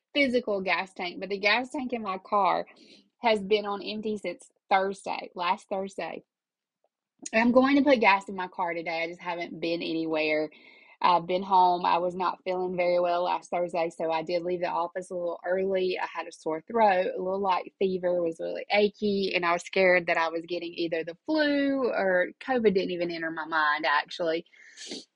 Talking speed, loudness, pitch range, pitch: 200 wpm, -27 LUFS, 170-205 Hz, 180 Hz